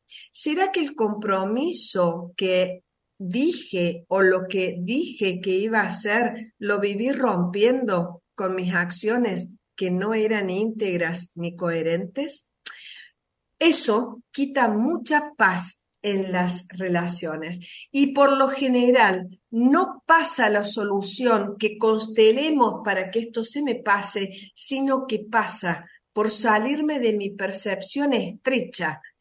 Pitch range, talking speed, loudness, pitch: 185-245 Hz, 120 wpm, -23 LUFS, 215 Hz